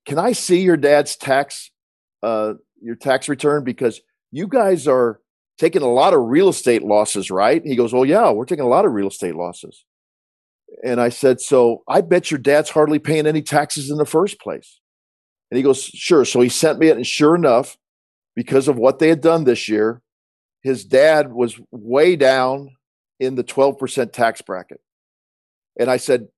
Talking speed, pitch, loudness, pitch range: 190 wpm, 135 Hz, -17 LUFS, 115-150 Hz